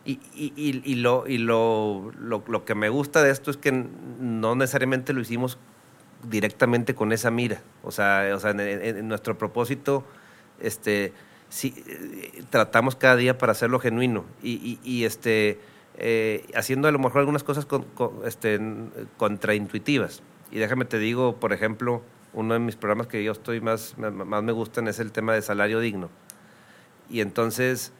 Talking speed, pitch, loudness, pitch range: 175 wpm, 115 Hz, -25 LUFS, 110-130 Hz